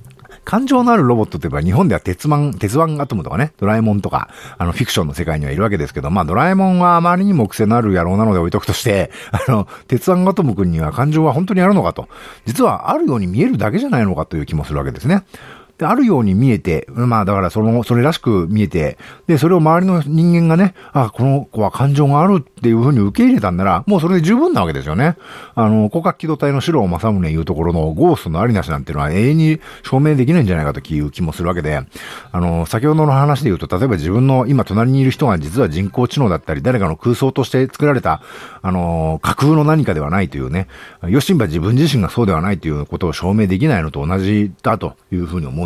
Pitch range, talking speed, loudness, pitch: 90-150 Hz, 485 characters per minute, -15 LUFS, 115 Hz